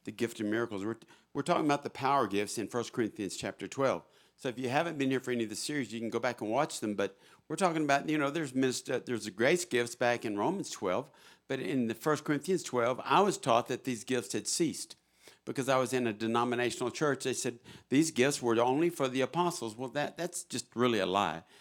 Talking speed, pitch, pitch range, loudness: 245 wpm, 125 Hz, 115-145 Hz, -32 LUFS